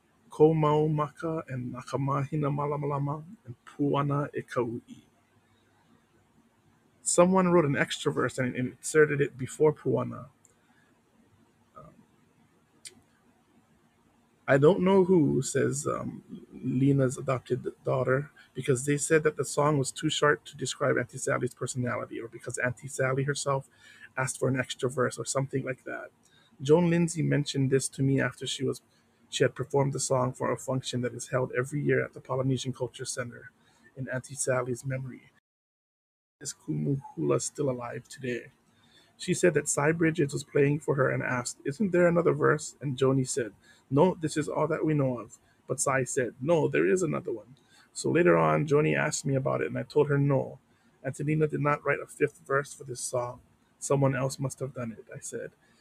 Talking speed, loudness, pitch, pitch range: 165 wpm, -28 LUFS, 135 Hz, 125-150 Hz